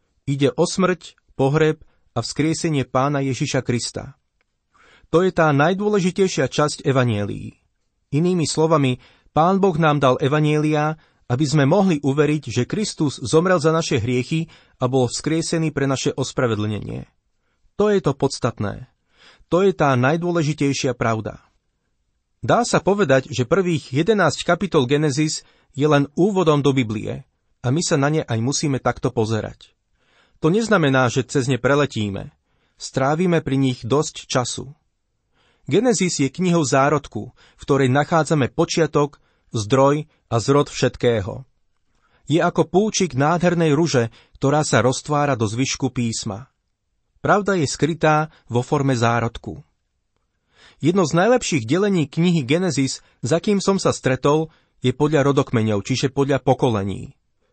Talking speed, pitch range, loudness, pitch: 130 wpm, 125-160 Hz, -20 LUFS, 145 Hz